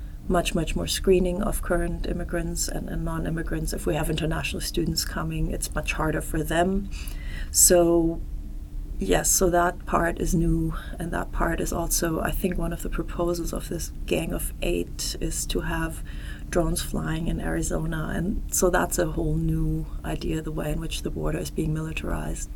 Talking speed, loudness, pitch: 180 wpm, -26 LUFS, 160 Hz